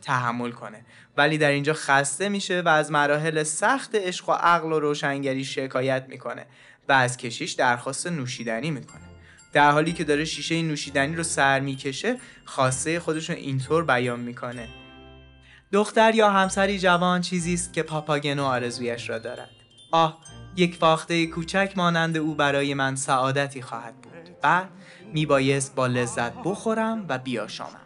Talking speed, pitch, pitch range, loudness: 145 wpm, 145 Hz, 130-170 Hz, -24 LUFS